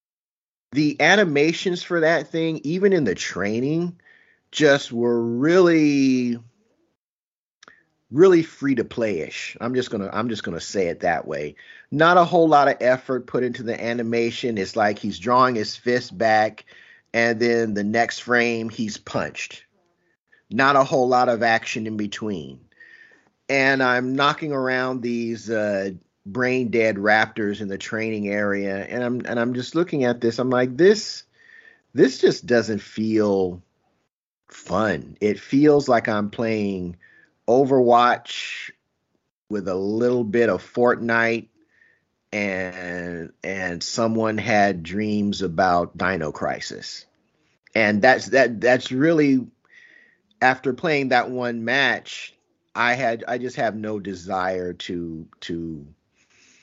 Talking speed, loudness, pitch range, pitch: 135 wpm, -21 LUFS, 105-140 Hz, 120 Hz